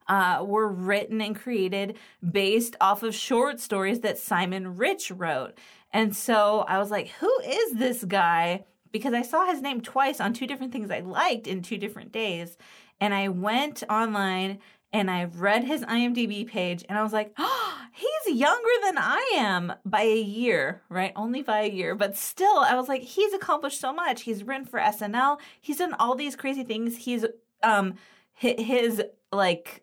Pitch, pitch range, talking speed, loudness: 220 Hz, 200-260 Hz, 180 wpm, -26 LUFS